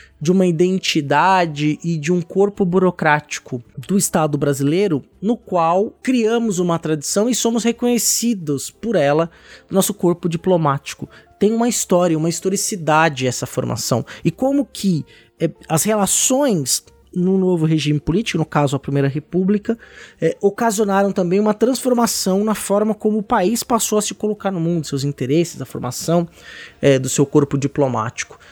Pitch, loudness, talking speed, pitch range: 180 Hz, -18 LUFS, 150 wpm, 150-210 Hz